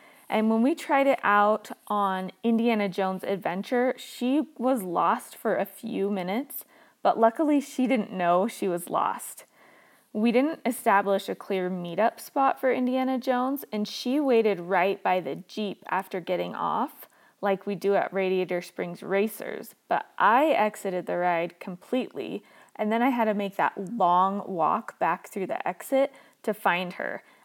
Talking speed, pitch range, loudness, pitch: 160 wpm, 190-255 Hz, -27 LUFS, 210 Hz